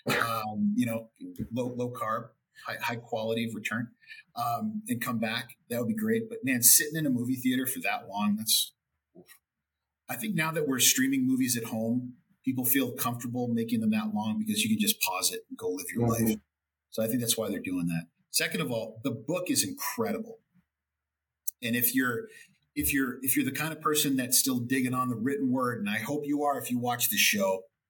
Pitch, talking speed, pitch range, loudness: 130 Hz, 215 wpm, 115-185 Hz, -28 LUFS